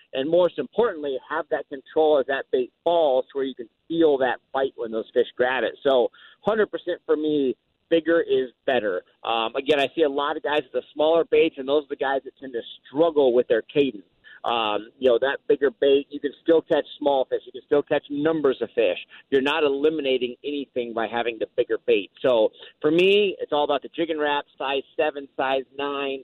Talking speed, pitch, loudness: 215 wpm, 155 Hz, -23 LUFS